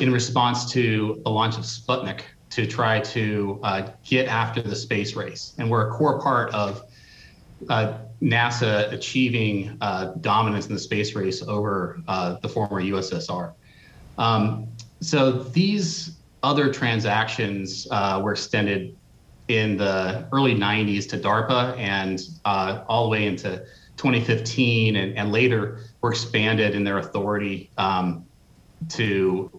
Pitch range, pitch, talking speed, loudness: 100-120 Hz, 110 Hz, 135 wpm, -23 LUFS